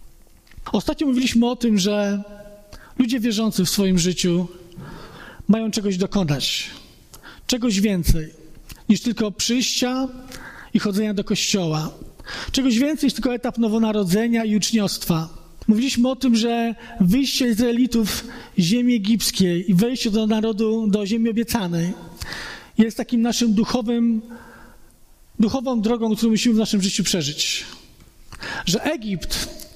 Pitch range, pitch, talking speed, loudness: 200-235 Hz, 220 Hz, 120 wpm, -21 LUFS